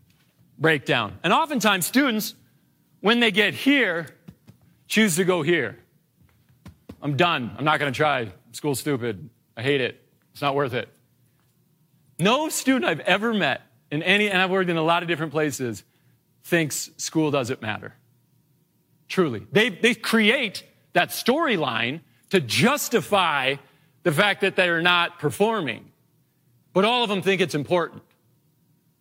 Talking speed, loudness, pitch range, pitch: 140 wpm, -22 LUFS, 140-200 Hz, 170 Hz